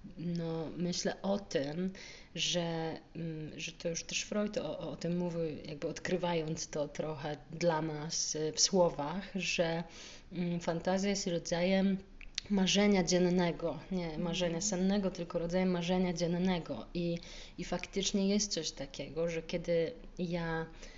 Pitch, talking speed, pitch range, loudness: 175 Hz, 125 wpm, 165-185 Hz, -35 LUFS